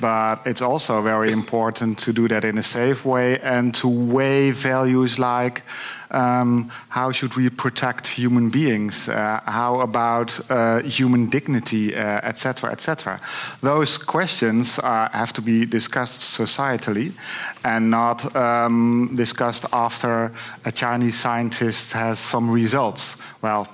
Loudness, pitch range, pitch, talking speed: -20 LUFS, 115-125 Hz, 120 Hz, 140 wpm